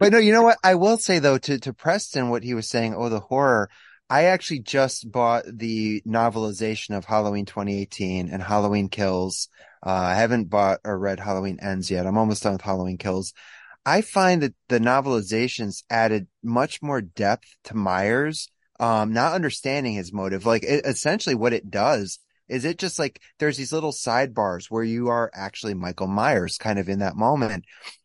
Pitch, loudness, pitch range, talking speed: 115 Hz, -23 LUFS, 100-135 Hz, 185 wpm